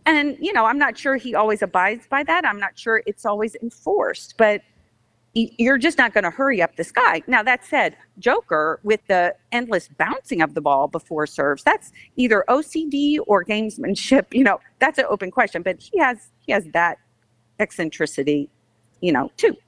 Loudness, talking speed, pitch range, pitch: -20 LUFS, 185 wpm, 165-265 Hz, 215 Hz